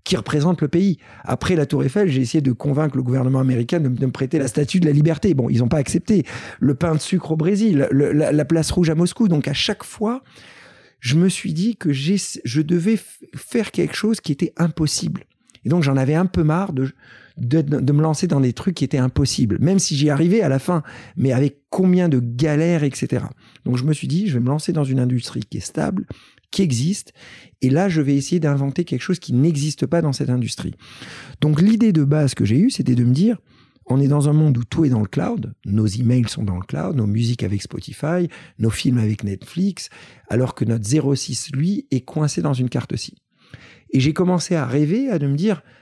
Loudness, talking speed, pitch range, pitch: -19 LUFS, 235 wpm, 130-175 Hz, 150 Hz